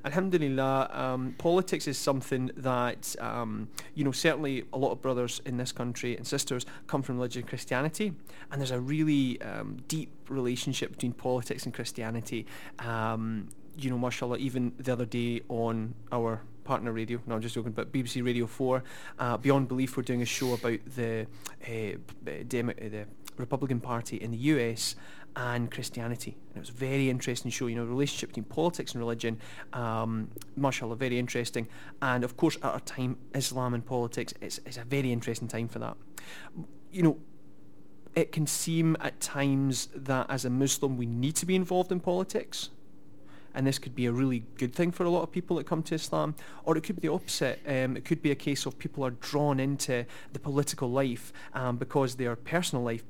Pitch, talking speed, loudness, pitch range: 130 Hz, 190 wpm, -32 LUFS, 120-140 Hz